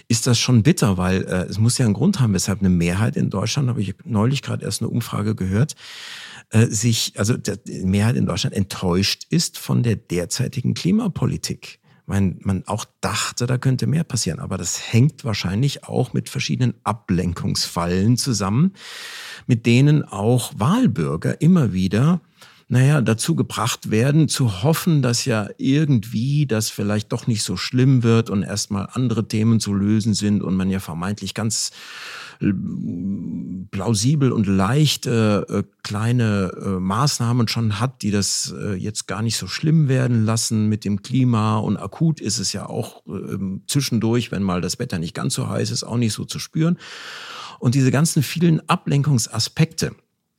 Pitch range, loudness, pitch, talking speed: 100-135 Hz, -20 LUFS, 115 Hz, 155 wpm